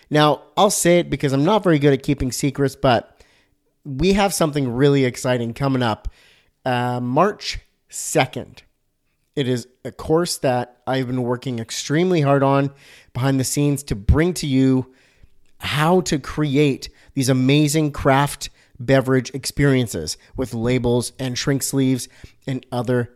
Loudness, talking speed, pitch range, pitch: -20 LUFS, 145 wpm, 125-145 Hz, 135 Hz